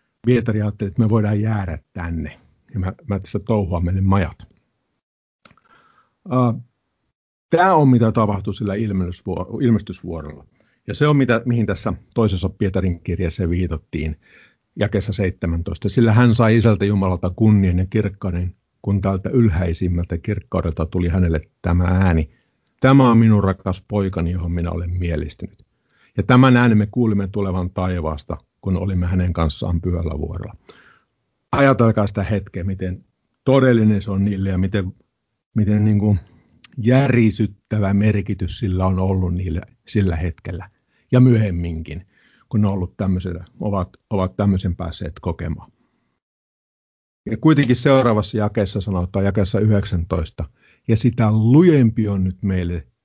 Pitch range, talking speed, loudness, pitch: 90-110 Hz, 130 wpm, -19 LUFS, 100 Hz